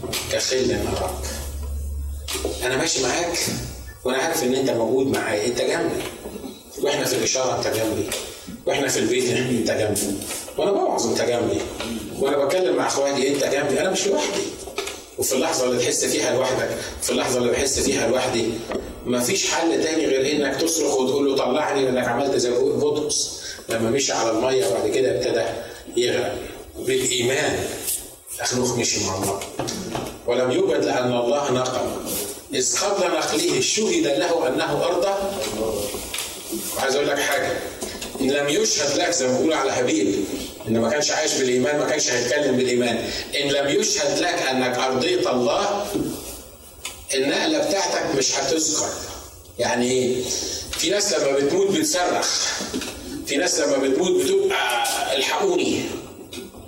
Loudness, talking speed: -22 LUFS, 140 wpm